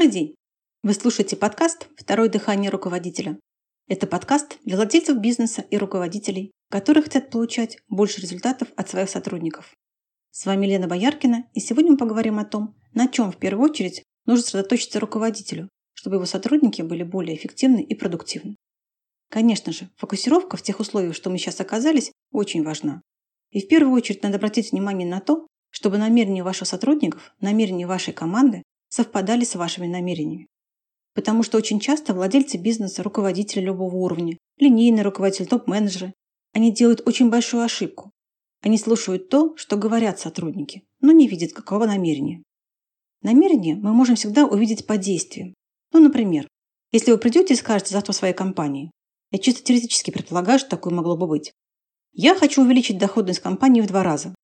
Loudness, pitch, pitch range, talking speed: -21 LUFS, 210 Hz, 190-240 Hz, 155 wpm